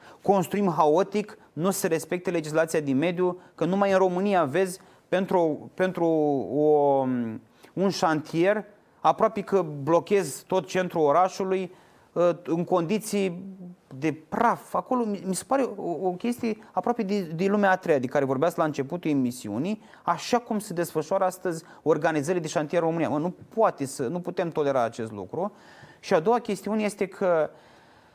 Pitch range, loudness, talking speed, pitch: 160-195 Hz, -26 LUFS, 150 wpm, 180 Hz